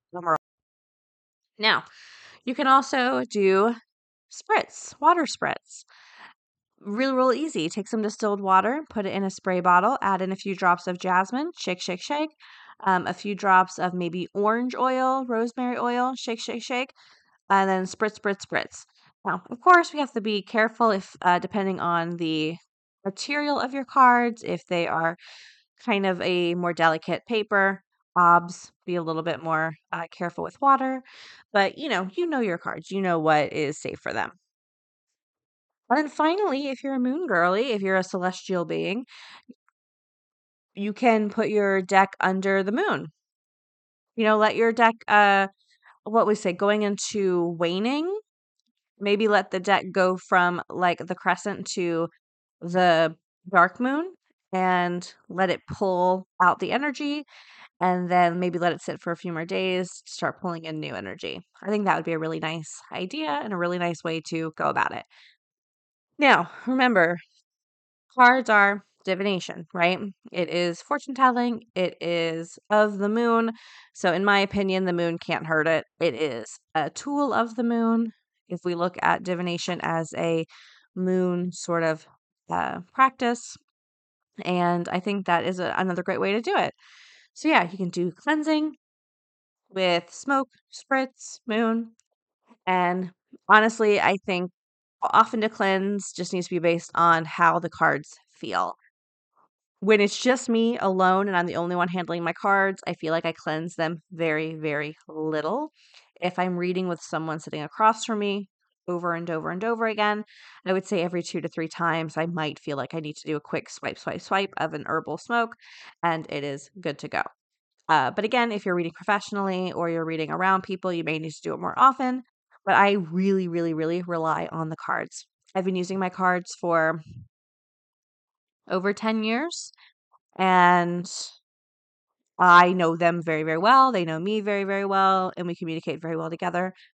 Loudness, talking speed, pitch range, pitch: -24 LUFS, 170 wpm, 170-220 Hz, 185 Hz